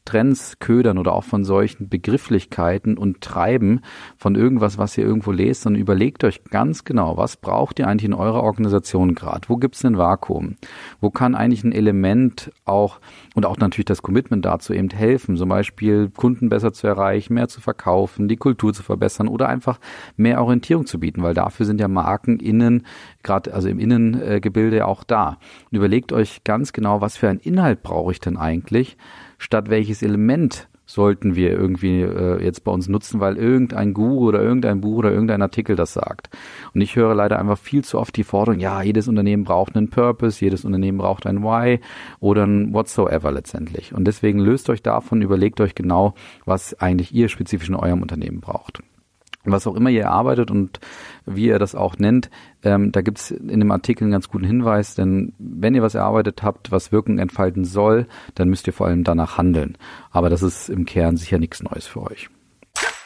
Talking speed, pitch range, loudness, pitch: 195 wpm, 95-115 Hz, -19 LUFS, 105 Hz